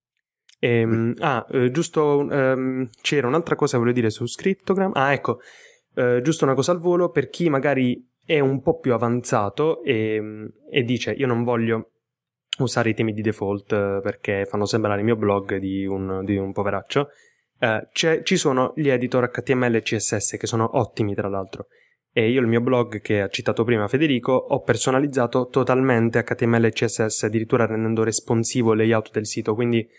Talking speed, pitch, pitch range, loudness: 175 wpm, 120 Hz, 110-135 Hz, -22 LUFS